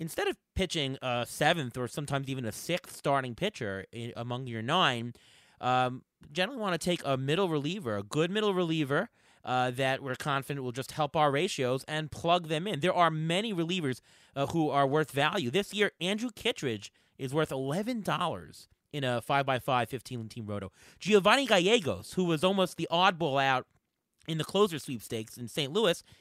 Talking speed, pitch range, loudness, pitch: 185 wpm, 125-175 Hz, -30 LUFS, 145 Hz